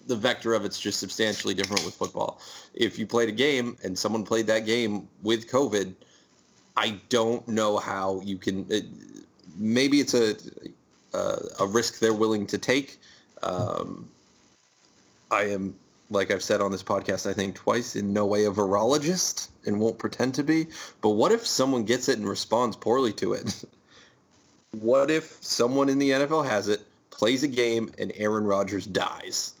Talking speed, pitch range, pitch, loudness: 175 wpm, 100-120 Hz, 110 Hz, -26 LUFS